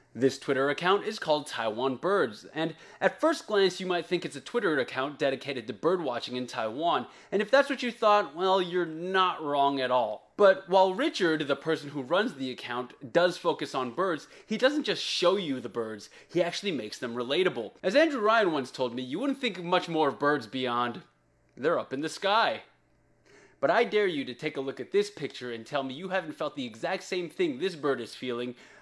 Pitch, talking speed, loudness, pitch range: 160 Hz, 220 wpm, -29 LUFS, 130-195 Hz